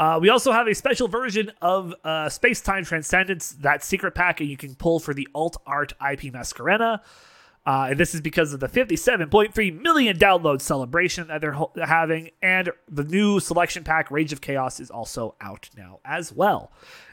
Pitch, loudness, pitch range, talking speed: 165 Hz, -22 LUFS, 150-195 Hz, 185 wpm